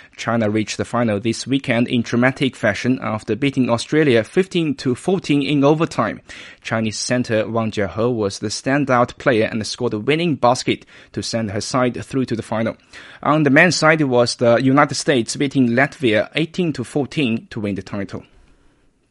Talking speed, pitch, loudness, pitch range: 165 wpm, 120 Hz, -18 LUFS, 110-140 Hz